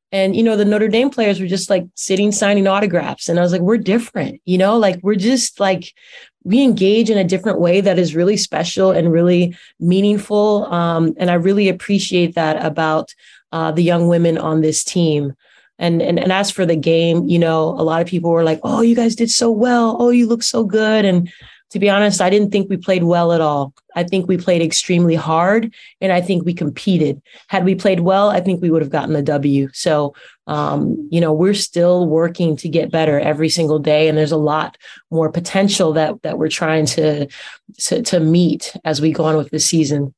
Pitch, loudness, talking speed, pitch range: 175 Hz, -16 LUFS, 220 wpm, 160-200 Hz